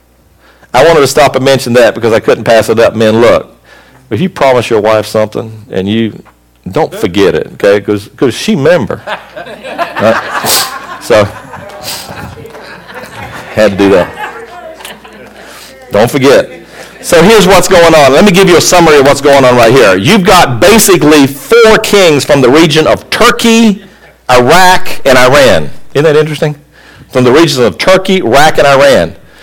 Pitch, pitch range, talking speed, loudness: 140 Hz, 110-185 Hz, 160 wpm, -6 LUFS